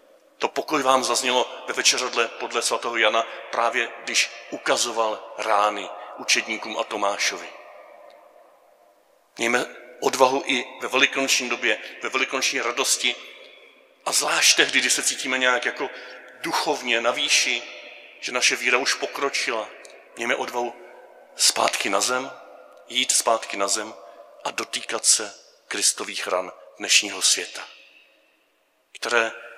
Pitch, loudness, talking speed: 130 Hz, -22 LUFS, 120 wpm